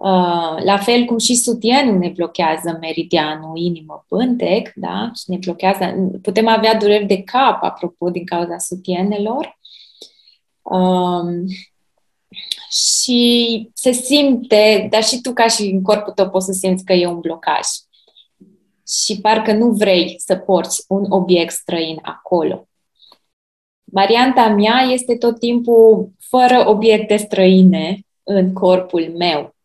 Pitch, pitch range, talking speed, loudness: 195 Hz, 180-225 Hz, 130 wpm, -15 LUFS